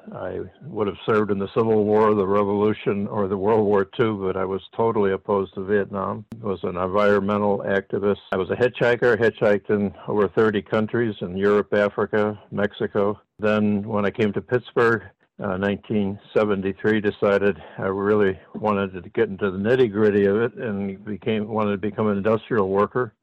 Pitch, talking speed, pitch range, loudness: 105 Hz, 175 wpm, 100-110 Hz, -22 LUFS